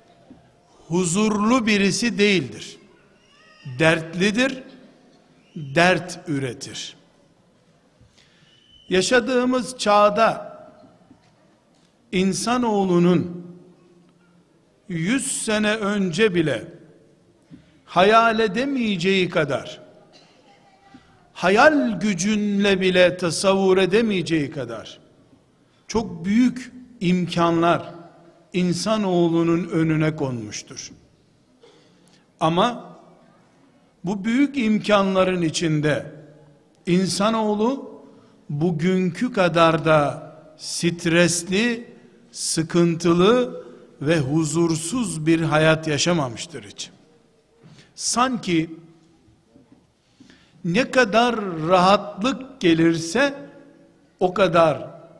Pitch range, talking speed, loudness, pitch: 165-220 Hz, 60 wpm, -20 LUFS, 180 Hz